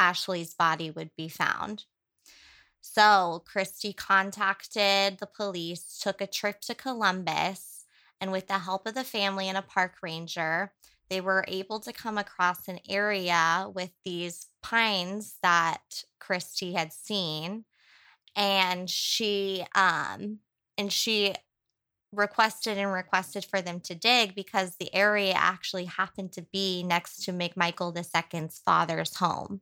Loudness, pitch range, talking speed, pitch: -28 LUFS, 175-205 Hz, 135 wpm, 190 Hz